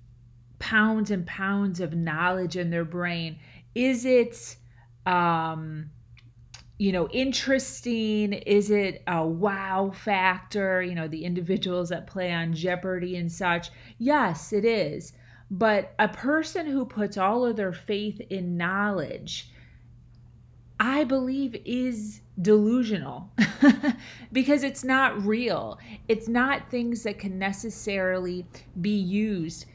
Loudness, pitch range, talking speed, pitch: -26 LUFS, 170-220 Hz, 120 wpm, 195 Hz